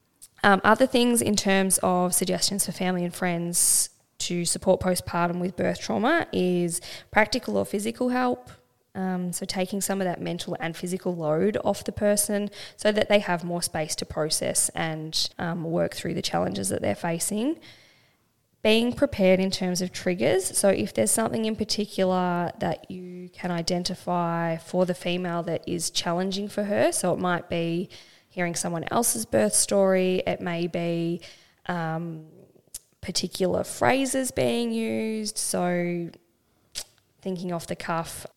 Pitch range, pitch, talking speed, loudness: 170-200 Hz, 180 Hz, 155 wpm, -25 LUFS